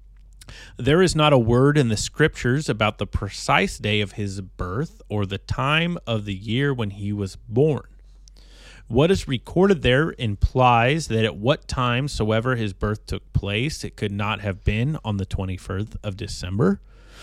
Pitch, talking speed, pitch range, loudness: 110 Hz, 175 wpm, 100-135 Hz, -22 LUFS